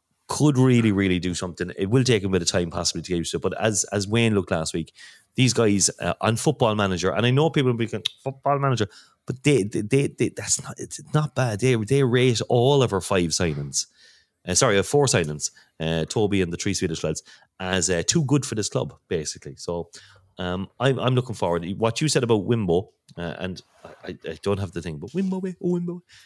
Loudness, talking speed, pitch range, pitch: -23 LUFS, 230 wpm, 90-130 Hz, 110 Hz